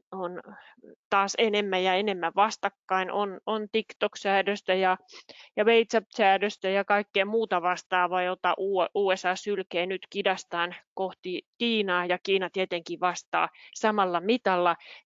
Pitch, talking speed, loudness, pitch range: 195 Hz, 115 wpm, -27 LUFS, 180-205 Hz